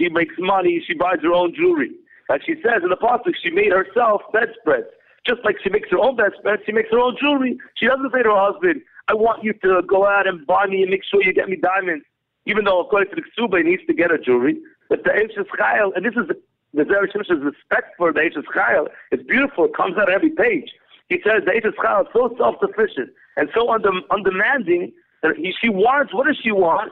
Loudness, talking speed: -19 LUFS, 240 wpm